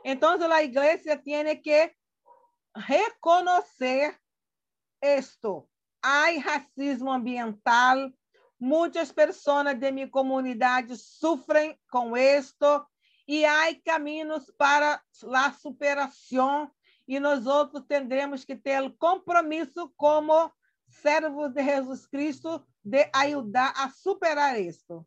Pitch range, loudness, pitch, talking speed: 270-315 Hz, -25 LUFS, 290 Hz, 100 wpm